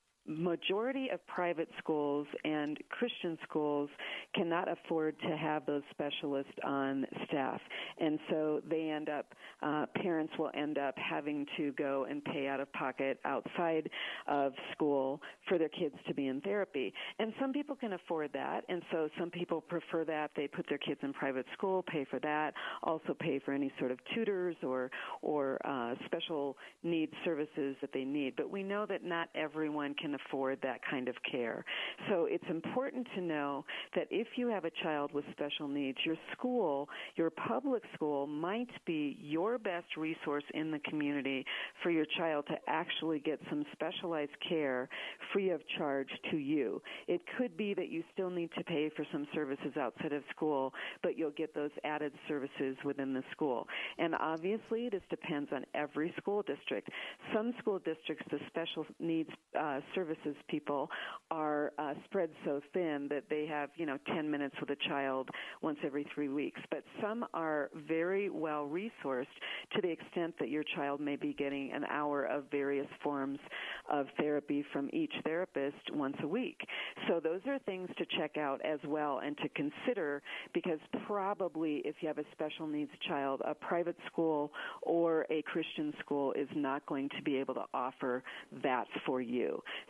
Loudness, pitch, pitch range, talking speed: -37 LUFS, 155 Hz, 145-175 Hz, 175 wpm